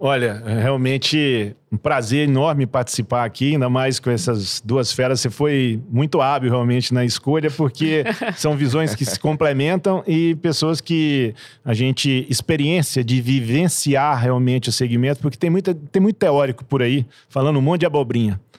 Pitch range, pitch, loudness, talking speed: 125-150 Hz, 135 Hz, -19 LUFS, 165 wpm